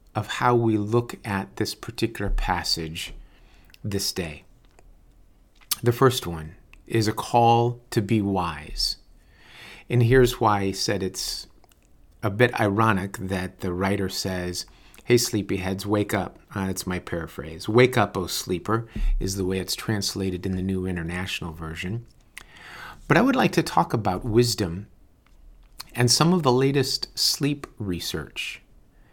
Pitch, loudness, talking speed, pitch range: 100 Hz, -24 LUFS, 145 wpm, 90-120 Hz